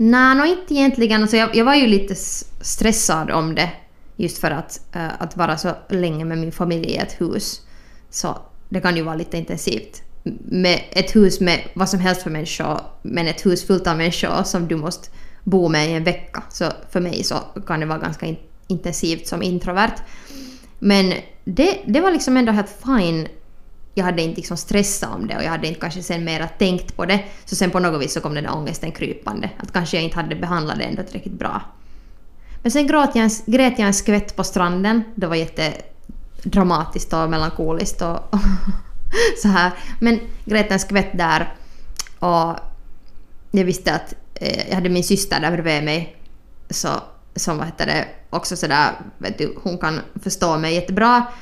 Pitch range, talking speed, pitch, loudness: 165-210 Hz, 190 wpm, 185 Hz, -20 LUFS